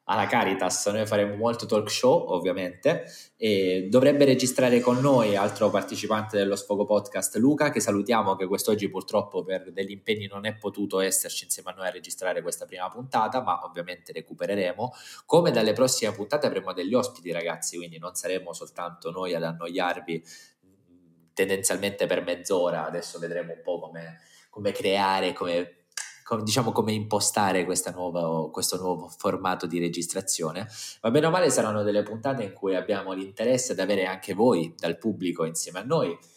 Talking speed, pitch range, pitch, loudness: 160 wpm, 90-110 Hz, 95 Hz, -26 LUFS